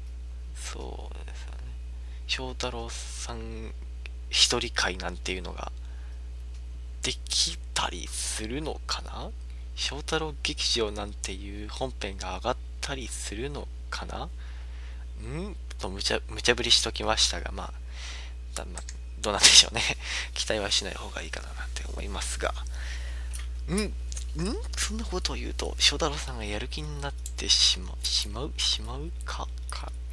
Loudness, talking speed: -27 LUFS, 275 characters per minute